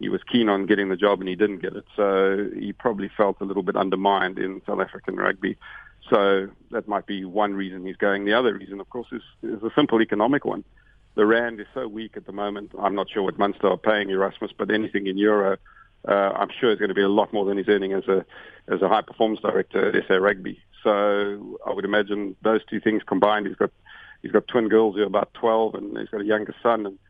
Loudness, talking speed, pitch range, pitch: -23 LUFS, 245 wpm, 100-110 Hz, 100 Hz